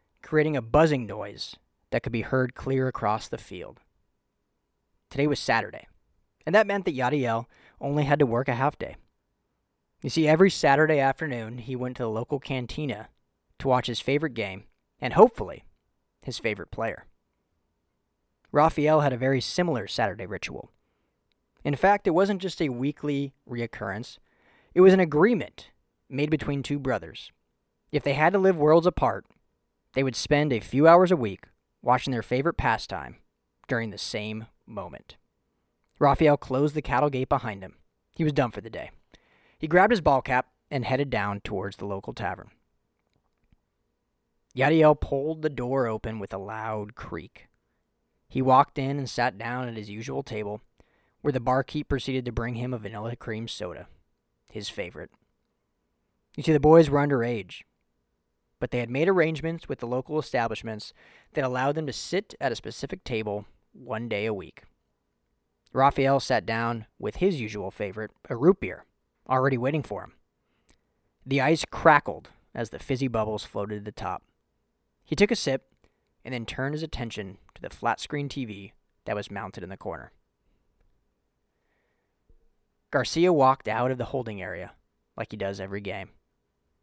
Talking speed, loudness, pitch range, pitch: 165 wpm, -26 LUFS, 105-145 Hz, 125 Hz